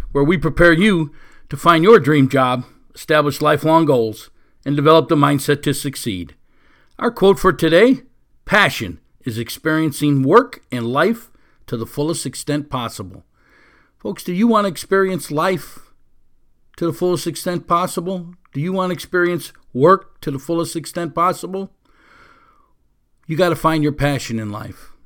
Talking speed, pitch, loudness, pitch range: 155 wpm, 160 Hz, -17 LUFS, 140-180 Hz